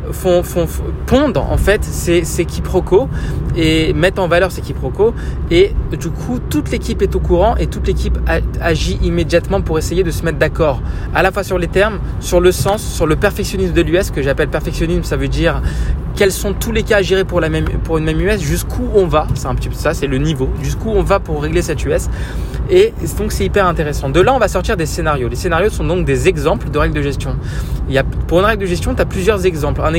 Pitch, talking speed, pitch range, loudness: 170 Hz, 240 wpm, 150-190 Hz, -15 LUFS